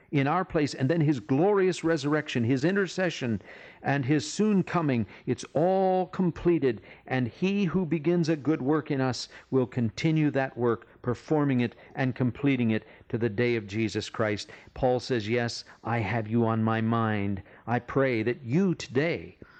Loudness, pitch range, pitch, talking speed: -28 LUFS, 115-160 Hz, 130 Hz, 170 wpm